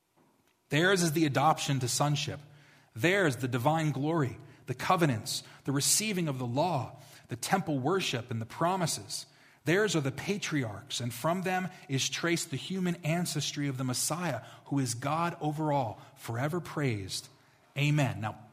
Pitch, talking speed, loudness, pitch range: 145 Hz, 150 wpm, -31 LUFS, 130-160 Hz